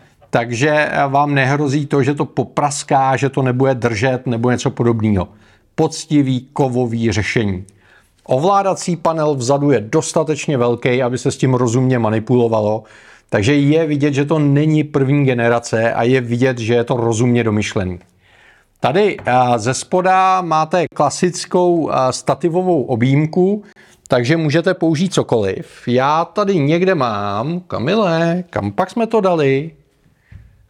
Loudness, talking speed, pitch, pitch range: -16 LUFS, 130 wpm, 140 Hz, 120-160 Hz